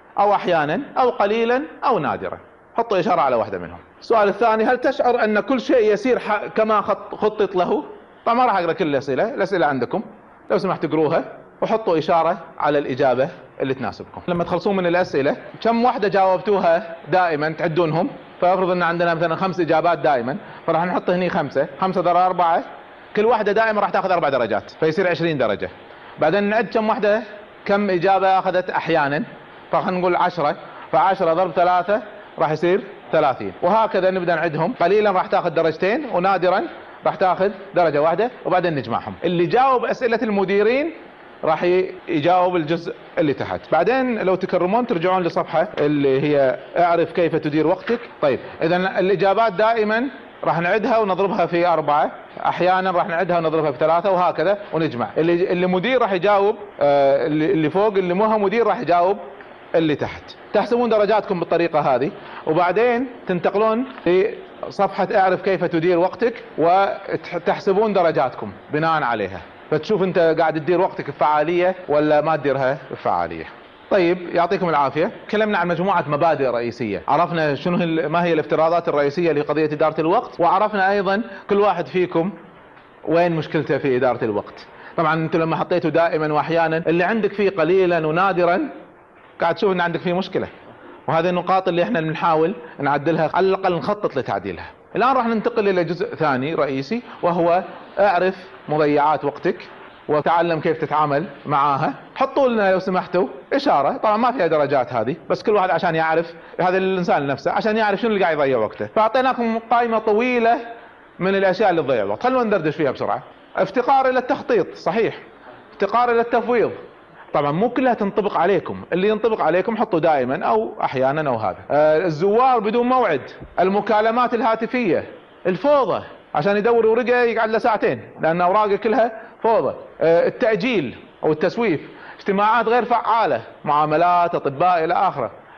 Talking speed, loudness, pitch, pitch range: 145 wpm, -19 LUFS, 185 Hz, 165-215 Hz